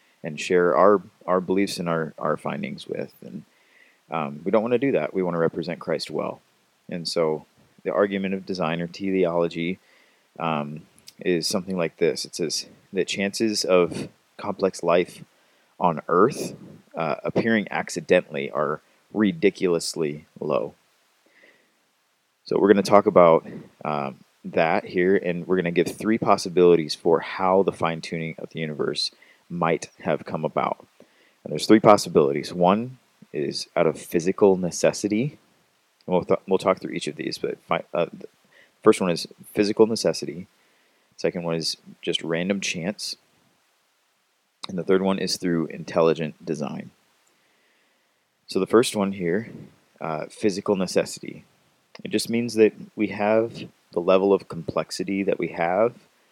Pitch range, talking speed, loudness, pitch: 85-100 Hz, 150 wpm, -24 LUFS, 95 Hz